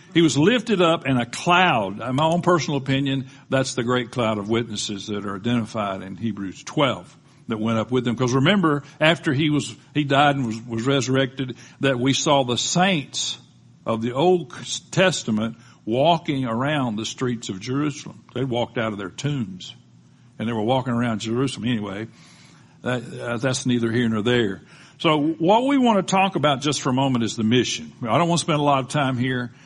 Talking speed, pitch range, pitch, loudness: 200 wpm, 115-150 Hz, 130 Hz, -22 LUFS